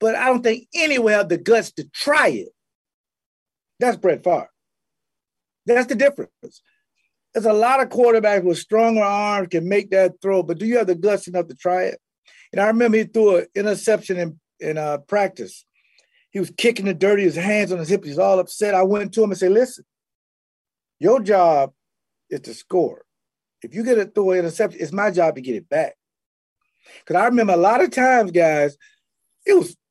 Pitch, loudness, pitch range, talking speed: 205 Hz, -19 LUFS, 185-235 Hz, 200 wpm